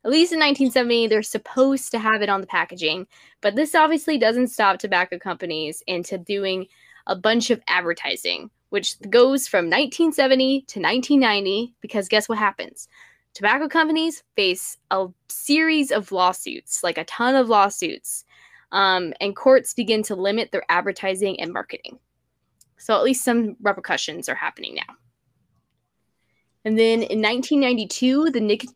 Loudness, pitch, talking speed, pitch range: -21 LUFS, 220 Hz, 150 wpm, 195-265 Hz